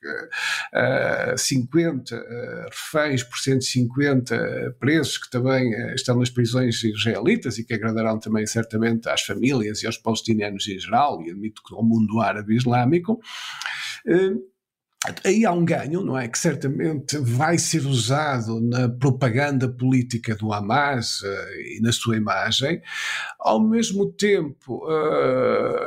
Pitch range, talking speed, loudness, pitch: 115-155 Hz, 125 wpm, -22 LUFS, 125 Hz